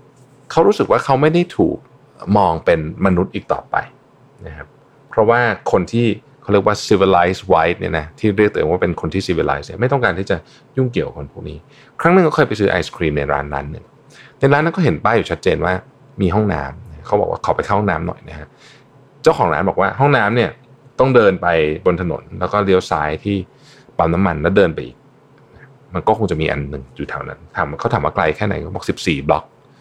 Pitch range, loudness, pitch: 85-135 Hz, -17 LUFS, 105 Hz